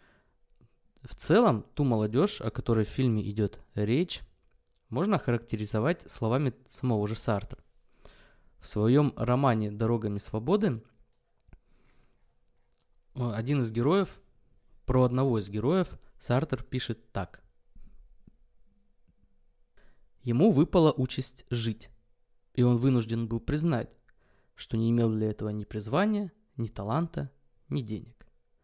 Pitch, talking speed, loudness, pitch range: 120 Hz, 105 wpm, -29 LUFS, 110-130 Hz